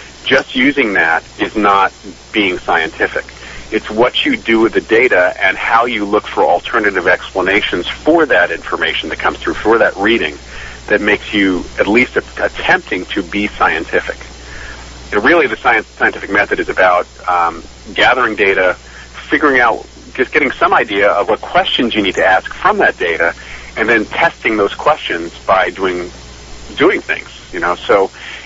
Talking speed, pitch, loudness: 165 wpm, 70 Hz, -13 LUFS